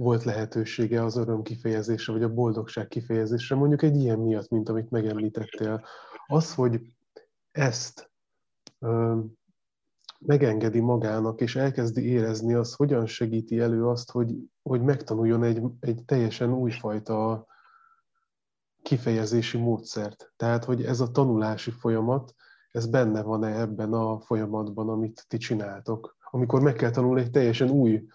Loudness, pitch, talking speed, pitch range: -27 LUFS, 115 Hz, 130 wpm, 110-125 Hz